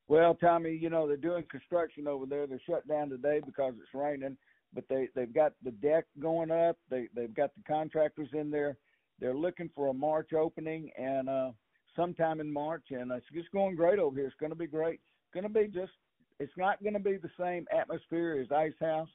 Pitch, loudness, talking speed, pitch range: 155 Hz, -33 LUFS, 220 wpm, 140-170 Hz